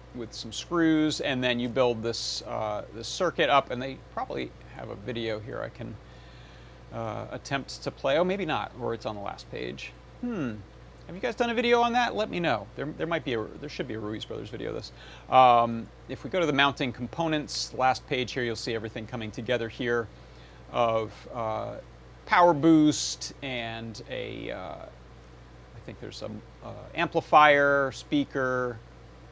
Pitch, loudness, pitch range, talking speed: 125 Hz, -27 LUFS, 115-150 Hz, 190 wpm